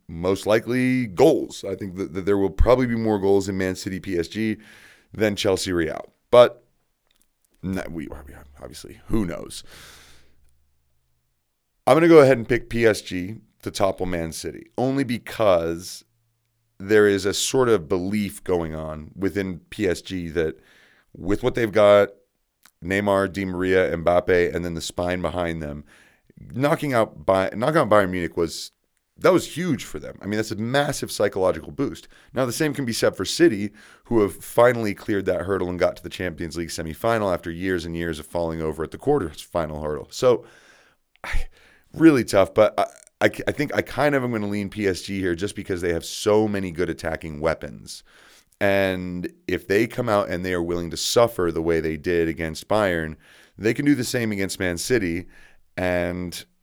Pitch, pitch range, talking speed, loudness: 95 Hz, 85-105 Hz, 175 wpm, -22 LUFS